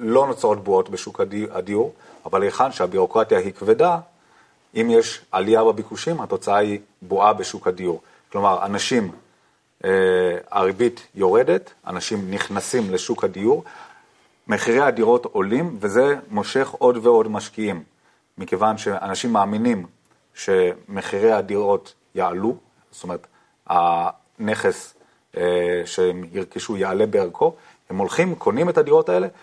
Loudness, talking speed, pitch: -21 LUFS, 115 wpm, 240 Hz